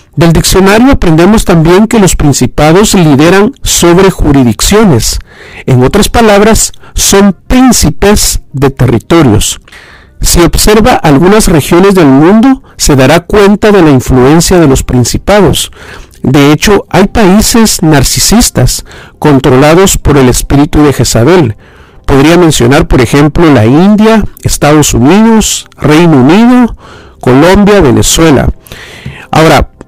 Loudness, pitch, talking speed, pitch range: -4 LUFS, 165 Hz, 110 wpm, 135-200 Hz